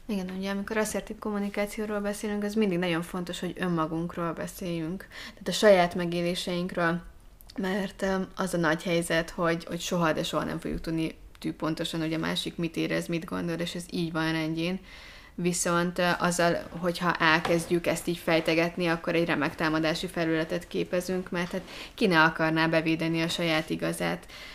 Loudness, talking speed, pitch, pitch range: -28 LUFS, 160 wpm, 175 Hz, 165-185 Hz